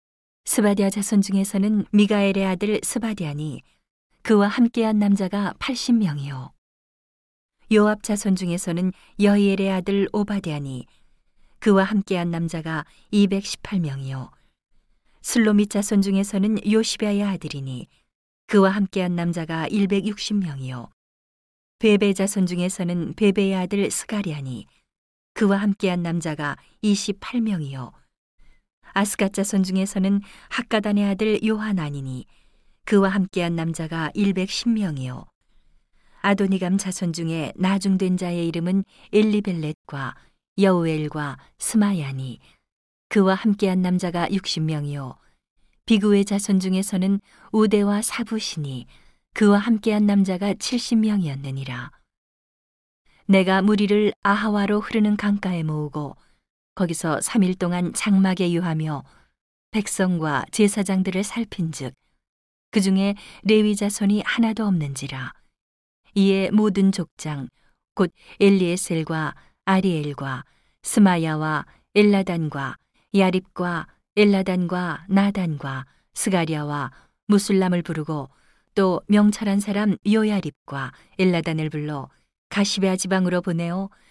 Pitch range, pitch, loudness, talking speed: 160-205 Hz, 190 Hz, -22 LUFS, 250 characters per minute